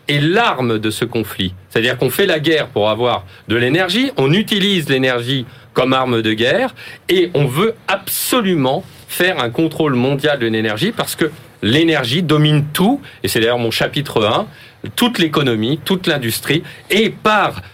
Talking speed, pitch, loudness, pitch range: 160 wpm, 145 Hz, -16 LUFS, 120-180 Hz